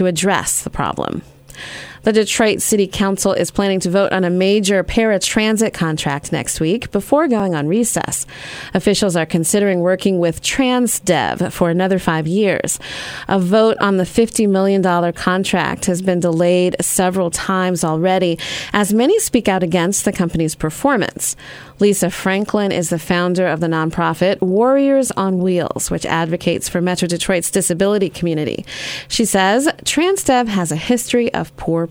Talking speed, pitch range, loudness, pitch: 150 wpm, 175-210 Hz, -16 LUFS, 190 Hz